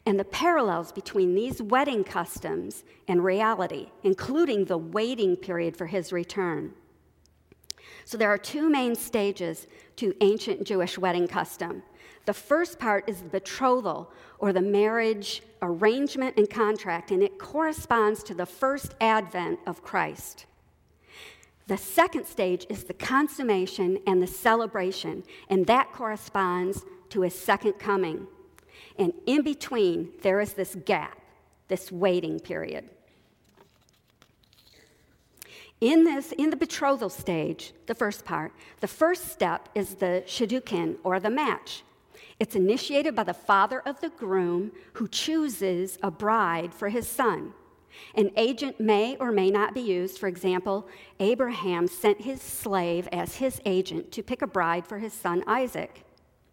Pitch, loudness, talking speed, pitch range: 205 Hz, -27 LUFS, 140 wpm, 185-255 Hz